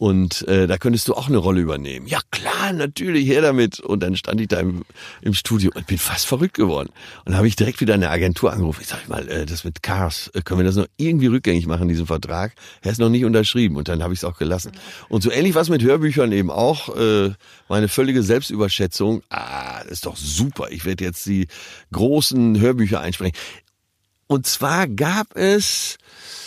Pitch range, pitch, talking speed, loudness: 90-125 Hz, 100 Hz, 210 wpm, -20 LUFS